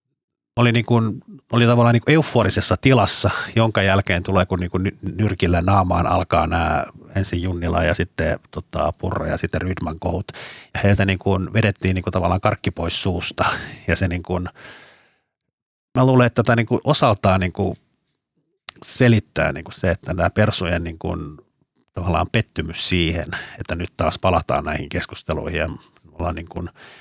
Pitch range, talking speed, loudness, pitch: 85-110 Hz, 155 wpm, -19 LUFS, 95 Hz